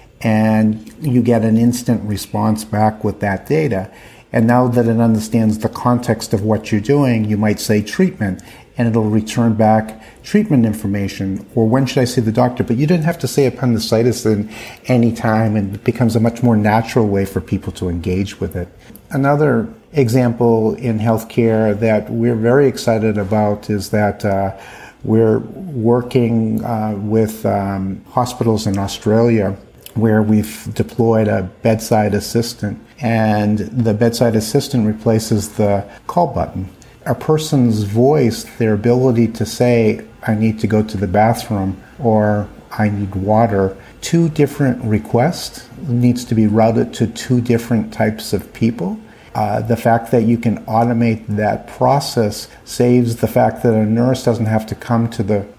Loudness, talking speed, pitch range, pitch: -16 LUFS, 160 wpm, 105-120 Hz, 110 Hz